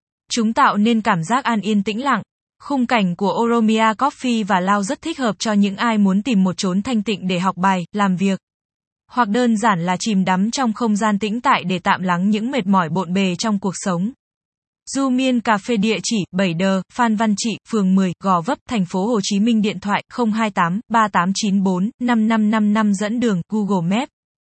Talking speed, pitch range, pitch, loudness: 200 wpm, 190-230 Hz, 215 Hz, -18 LUFS